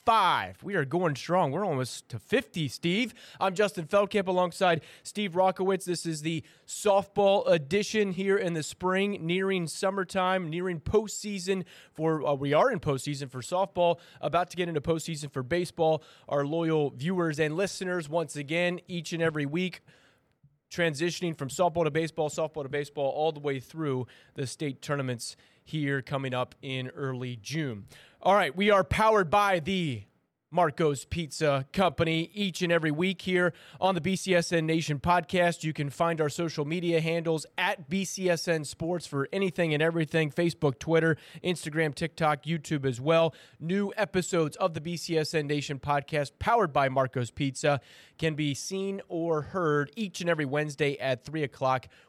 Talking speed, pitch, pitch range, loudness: 160 wpm, 165 Hz, 145-180 Hz, -29 LUFS